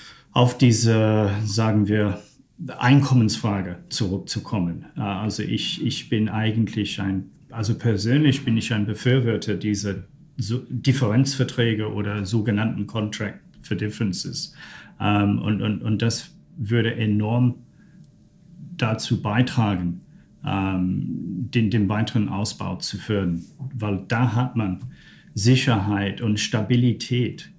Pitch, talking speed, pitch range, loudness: 110 Hz, 100 wpm, 105-125 Hz, -23 LUFS